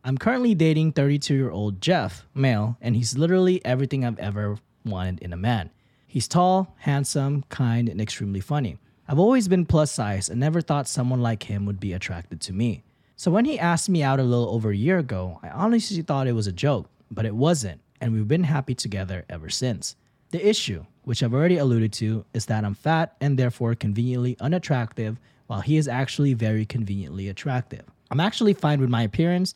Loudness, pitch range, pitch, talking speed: -24 LUFS, 110-150 Hz, 125 Hz, 200 wpm